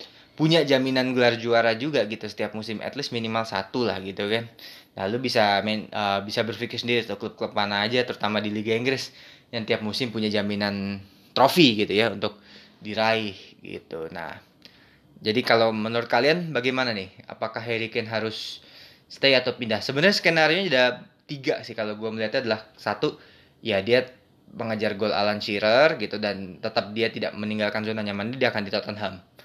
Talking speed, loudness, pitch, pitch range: 175 wpm, -24 LUFS, 110 Hz, 105-125 Hz